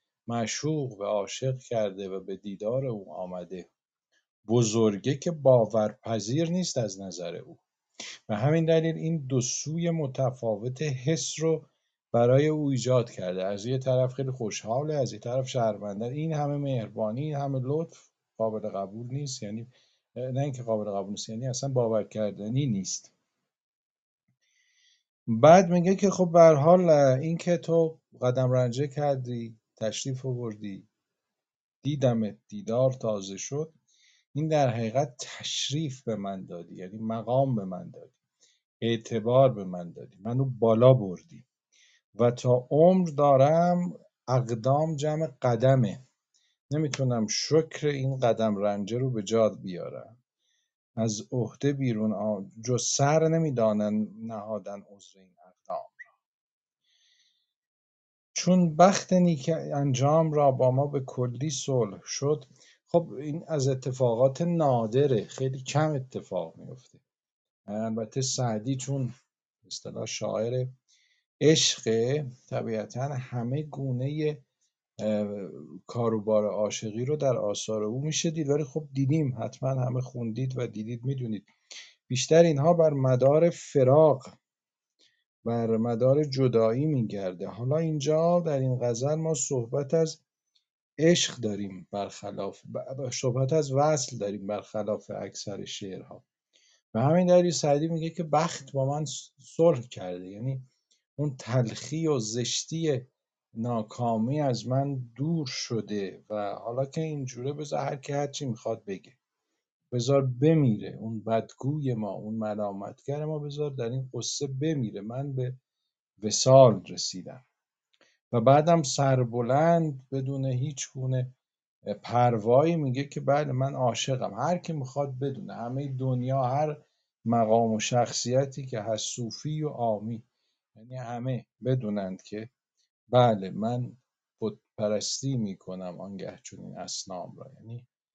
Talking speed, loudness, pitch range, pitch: 125 wpm, -27 LUFS, 115-150 Hz, 130 Hz